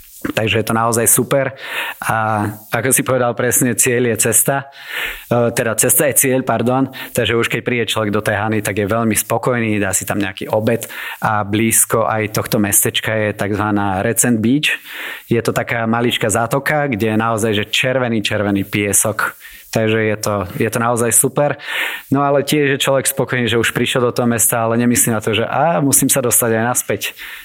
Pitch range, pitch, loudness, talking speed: 110-130 Hz, 115 Hz, -15 LUFS, 190 wpm